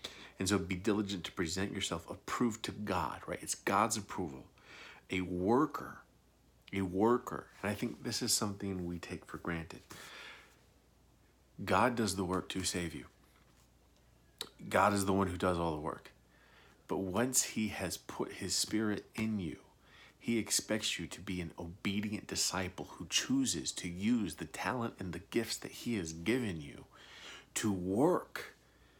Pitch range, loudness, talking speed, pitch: 90-105 Hz, -36 LUFS, 160 wpm, 95 Hz